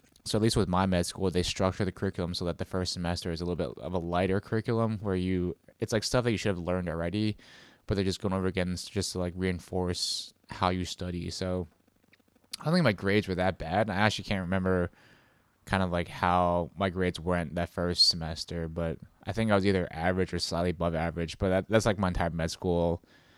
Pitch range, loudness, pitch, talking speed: 85-100 Hz, -30 LUFS, 90 Hz, 235 wpm